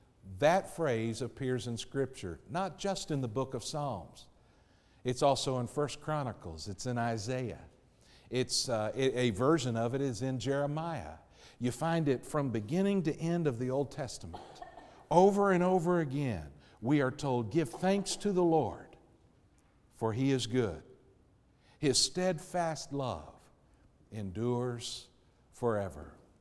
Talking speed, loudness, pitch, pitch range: 140 wpm, -33 LUFS, 130 Hz, 115-155 Hz